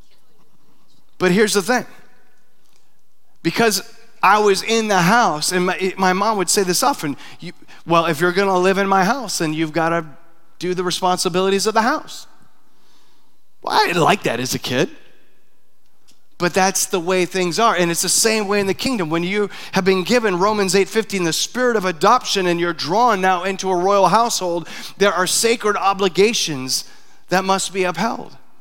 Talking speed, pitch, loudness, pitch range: 185 wpm, 190 Hz, -17 LUFS, 180-210 Hz